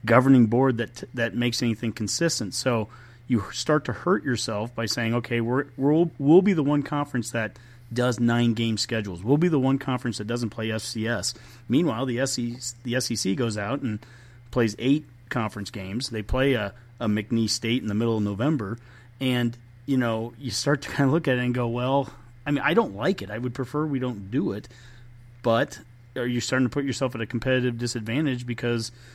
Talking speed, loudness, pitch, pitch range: 205 wpm, -25 LUFS, 120 Hz, 115-130 Hz